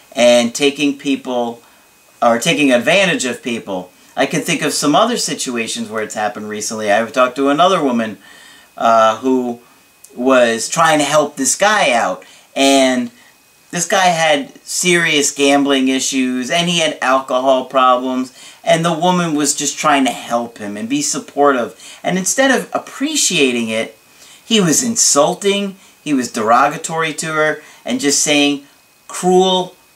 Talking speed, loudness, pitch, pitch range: 150 wpm, -14 LUFS, 140 Hz, 125-170 Hz